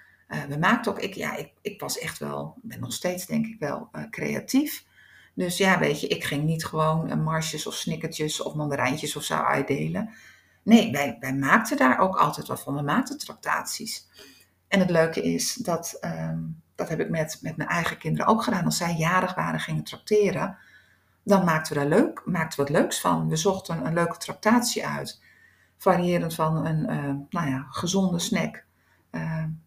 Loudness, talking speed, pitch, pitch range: -25 LUFS, 190 wpm, 160 Hz, 145-195 Hz